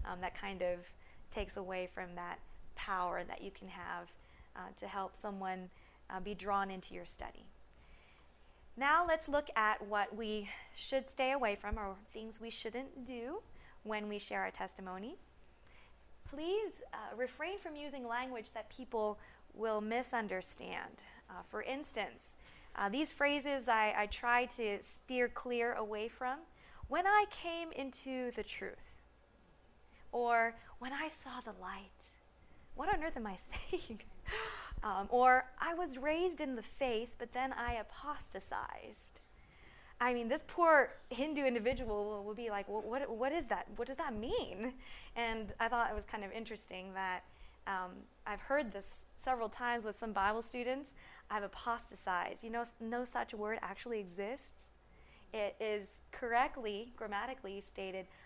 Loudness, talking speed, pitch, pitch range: -39 LUFS, 150 wpm, 230 Hz, 205-260 Hz